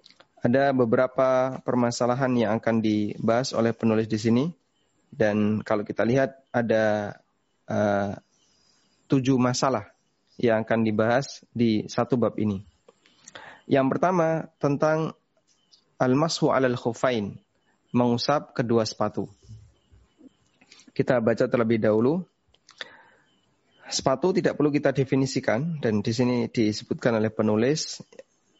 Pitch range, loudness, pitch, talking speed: 110-135 Hz, -24 LUFS, 120 Hz, 105 wpm